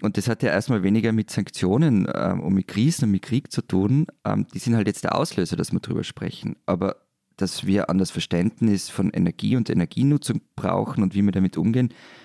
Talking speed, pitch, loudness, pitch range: 205 wpm, 110 Hz, -23 LUFS, 100-120 Hz